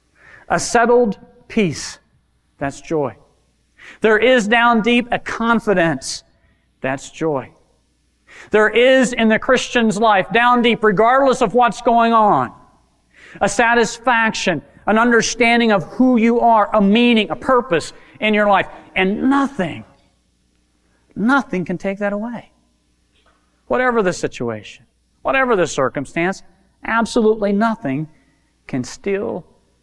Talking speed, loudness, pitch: 115 wpm, -16 LUFS, 210 Hz